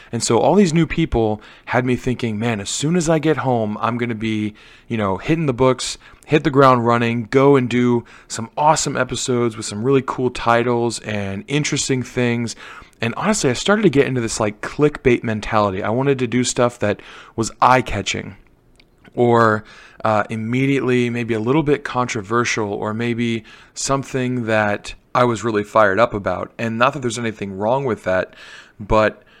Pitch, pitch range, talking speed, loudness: 120 Hz, 110-130 Hz, 185 wpm, -19 LUFS